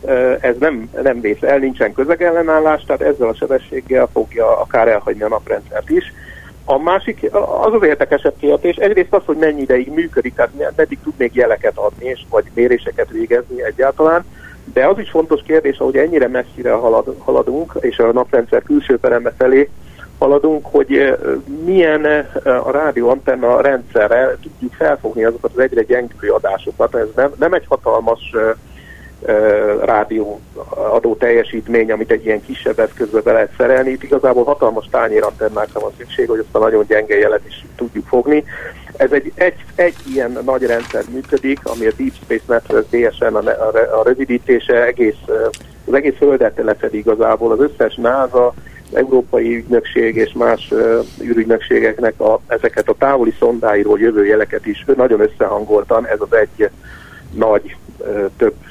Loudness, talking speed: -15 LUFS, 155 wpm